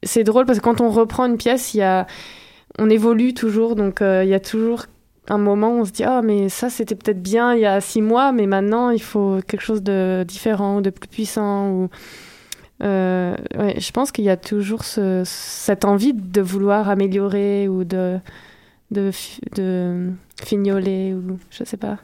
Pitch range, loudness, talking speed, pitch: 195-225 Hz, -19 LUFS, 210 wpm, 205 Hz